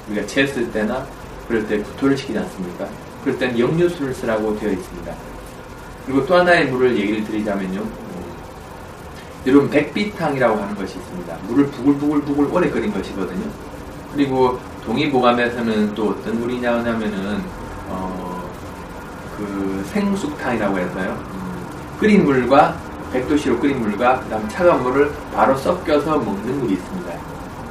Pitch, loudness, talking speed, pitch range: 120 Hz, -20 LUFS, 330 characters per minute, 100-140 Hz